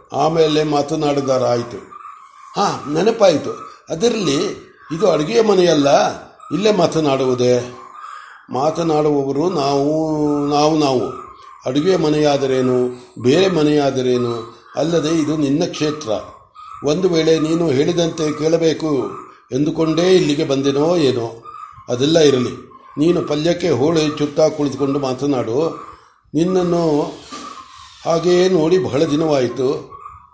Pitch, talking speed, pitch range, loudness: 155 Hz, 85 wpm, 140-170 Hz, -17 LUFS